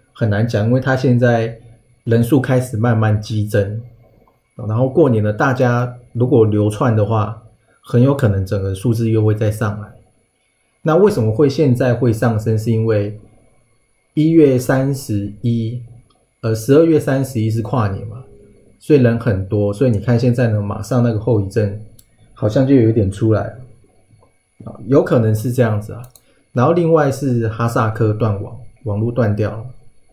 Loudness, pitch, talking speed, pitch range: -16 LUFS, 115 Hz, 245 characters per minute, 110-125 Hz